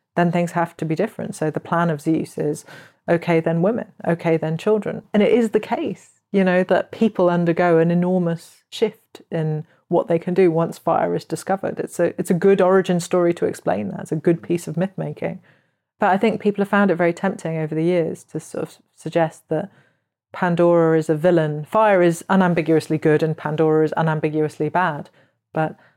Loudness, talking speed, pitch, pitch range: -20 LUFS, 205 wpm, 170 Hz, 160-190 Hz